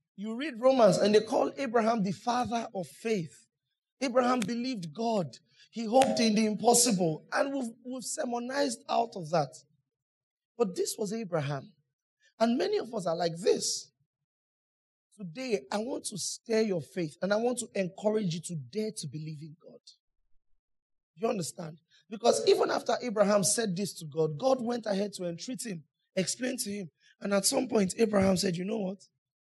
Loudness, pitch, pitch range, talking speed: -30 LUFS, 205 Hz, 165-235 Hz, 170 wpm